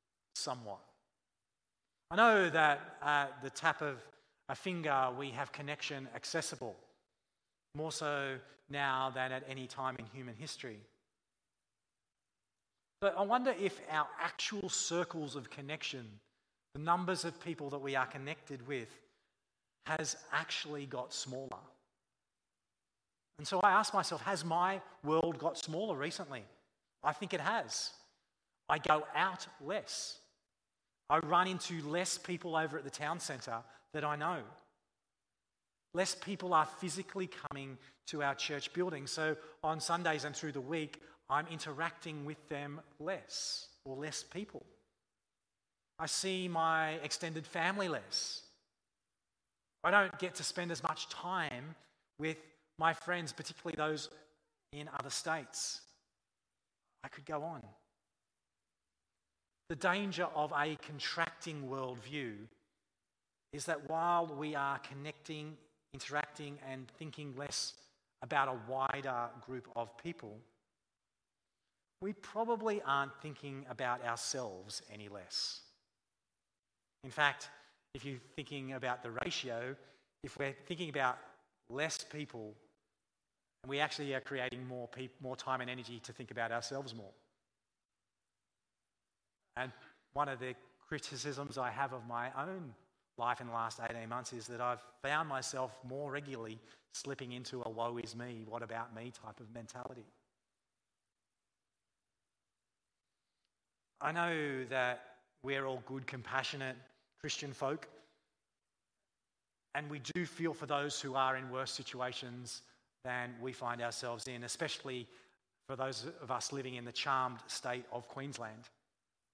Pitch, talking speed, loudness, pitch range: 140 Hz, 130 wpm, -38 LUFS, 125-155 Hz